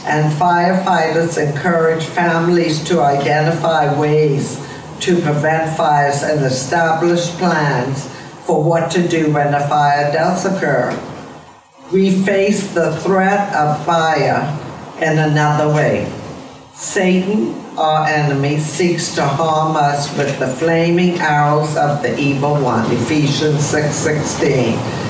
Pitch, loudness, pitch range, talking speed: 155 Hz, -15 LUFS, 145-170 Hz, 115 wpm